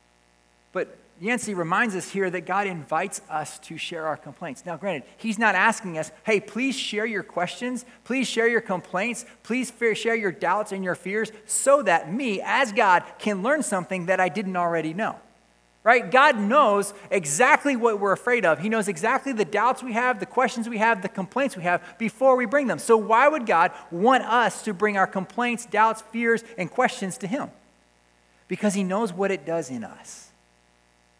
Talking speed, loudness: 190 wpm, -23 LUFS